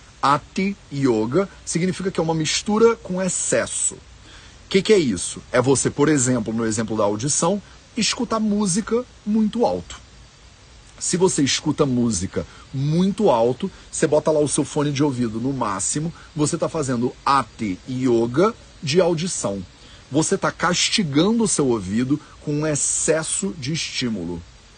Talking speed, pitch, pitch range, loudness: 145 wpm, 150 Hz, 125-185 Hz, -21 LUFS